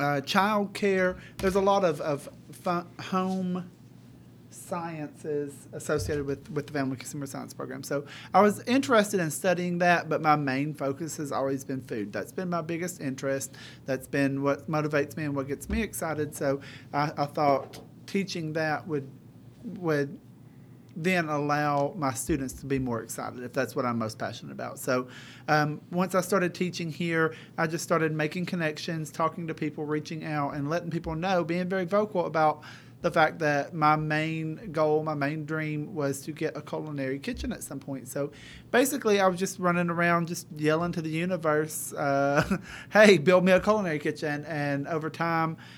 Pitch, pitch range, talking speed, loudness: 155 Hz, 140-175 Hz, 180 wpm, -28 LUFS